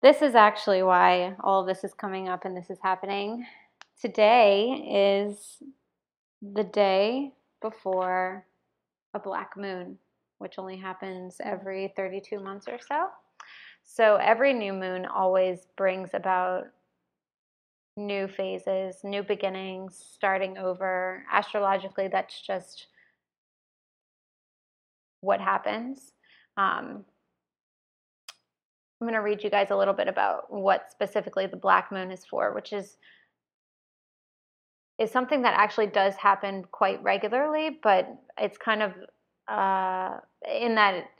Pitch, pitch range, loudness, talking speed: 195 Hz, 190-215 Hz, -26 LUFS, 120 wpm